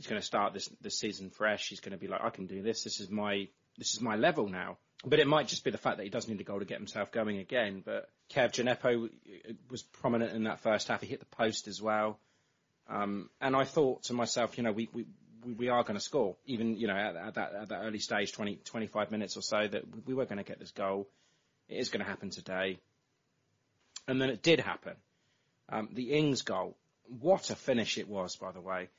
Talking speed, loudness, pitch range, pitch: 245 wpm, -34 LUFS, 100-125 Hz, 115 Hz